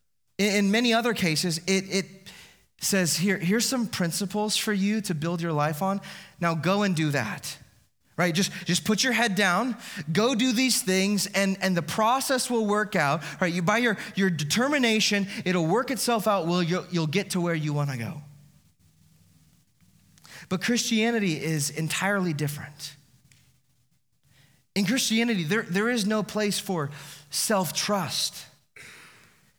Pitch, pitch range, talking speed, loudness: 190 Hz, 155-210 Hz, 150 wpm, -25 LUFS